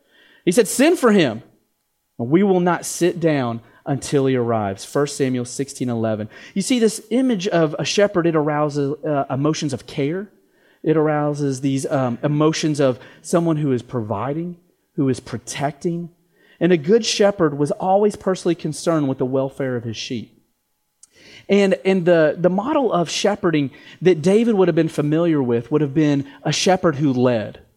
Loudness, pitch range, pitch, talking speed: -19 LUFS, 135-180 Hz, 155 Hz, 170 wpm